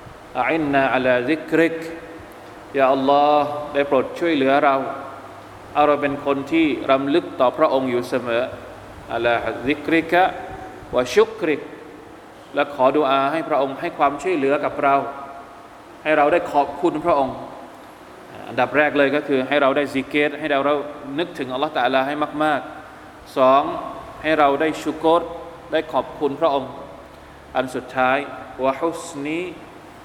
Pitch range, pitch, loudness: 135-155 Hz, 145 Hz, -20 LUFS